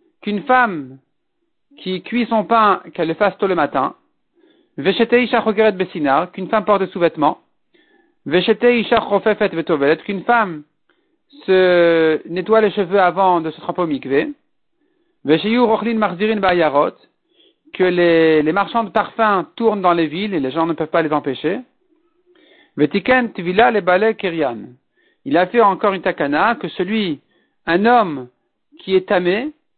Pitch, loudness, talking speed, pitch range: 205 Hz, -17 LUFS, 120 wpm, 175-245 Hz